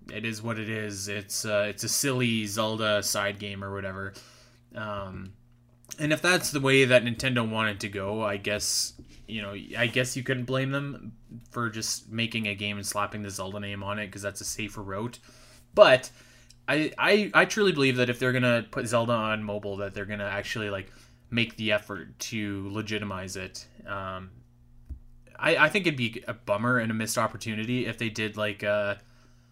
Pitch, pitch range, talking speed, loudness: 110 Hz, 100-120 Hz, 195 wpm, -27 LUFS